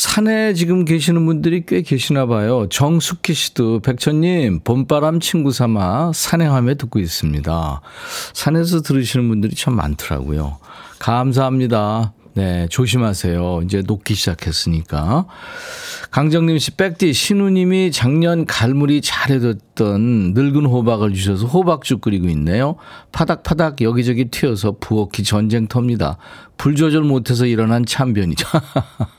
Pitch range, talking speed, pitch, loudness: 105-160 Hz, 305 characters per minute, 130 Hz, -17 LUFS